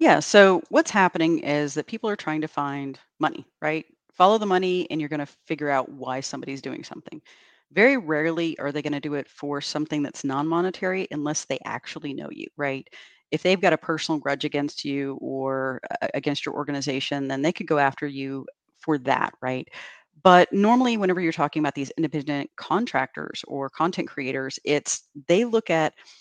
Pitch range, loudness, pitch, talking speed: 140-175 Hz, -24 LUFS, 150 Hz, 190 wpm